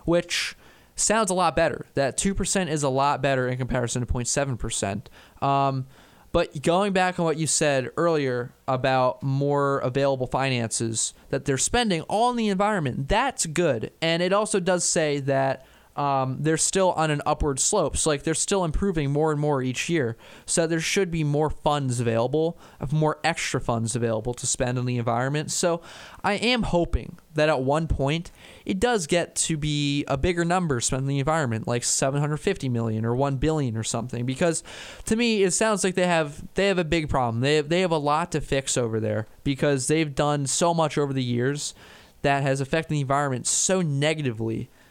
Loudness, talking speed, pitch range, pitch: -24 LUFS, 190 wpm, 130-170 Hz, 150 Hz